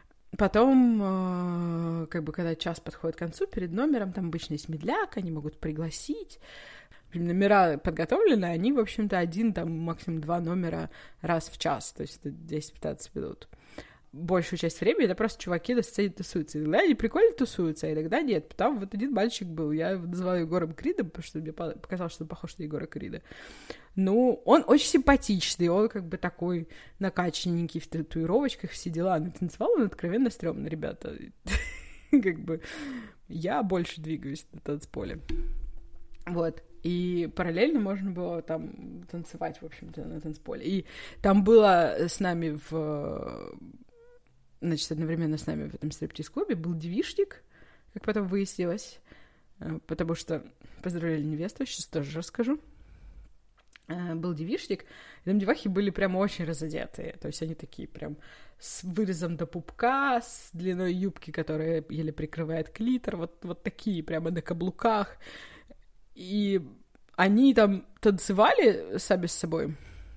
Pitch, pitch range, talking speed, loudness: 175 Hz, 160-205 Hz, 145 wpm, -29 LUFS